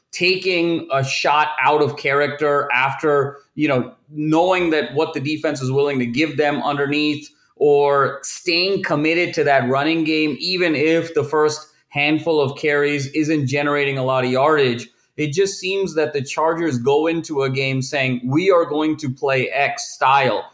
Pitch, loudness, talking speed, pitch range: 150 Hz, -18 LUFS, 170 wpm, 140-160 Hz